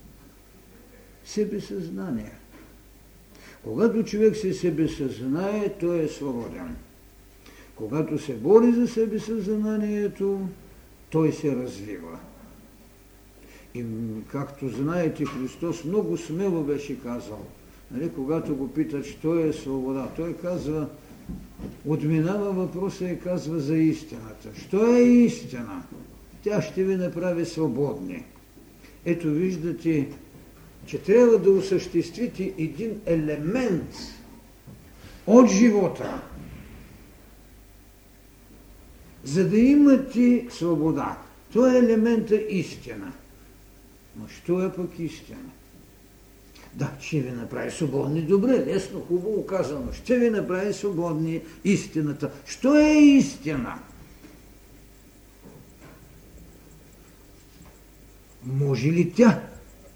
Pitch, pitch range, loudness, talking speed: 165 Hz, 140-200 Hz, -24 LUFS, 90 wpm